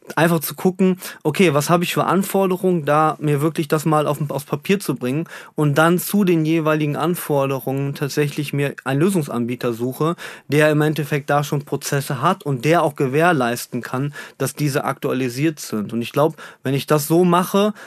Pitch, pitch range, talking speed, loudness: 150 Hz, 140-170 Hz, 180 wpm, -19 LUFS